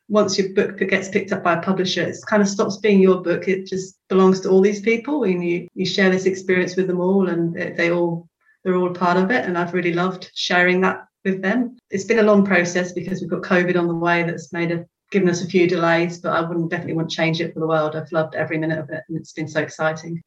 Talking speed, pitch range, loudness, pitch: 265 wpm, 170-190 Hz, -20 LUFS, 180 Hz